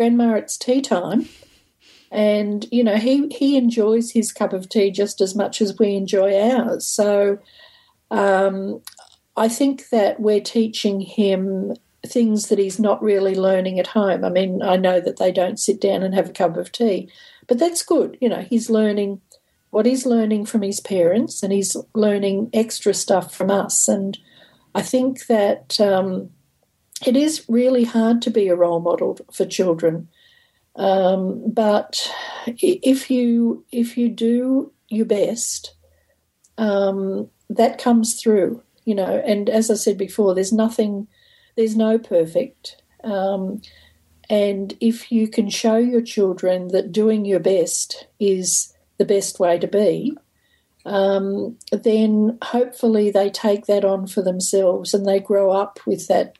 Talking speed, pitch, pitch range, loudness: 155 wpm, 210 Hz, 195-230 Hz, -19 LUFS